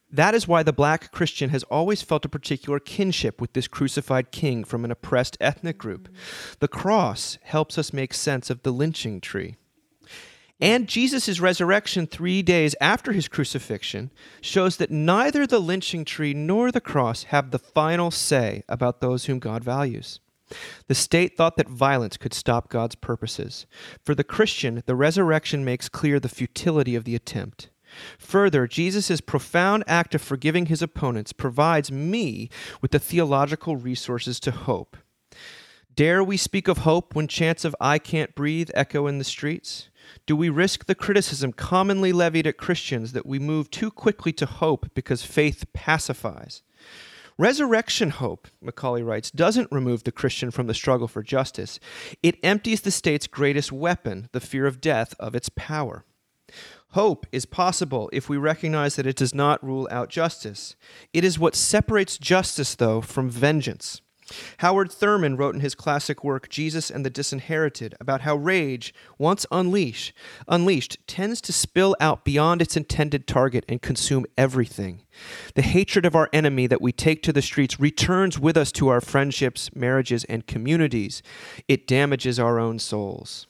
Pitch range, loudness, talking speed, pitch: 125-170 Hz, -23 LUFS, 165 wpm, 145 Hz